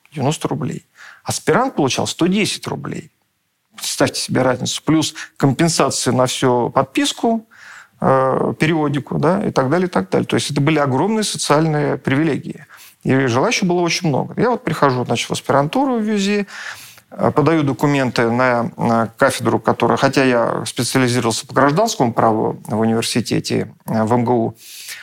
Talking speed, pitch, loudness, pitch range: 140 wpm, 140 Hz, -17 LUFS, 125-165 Hz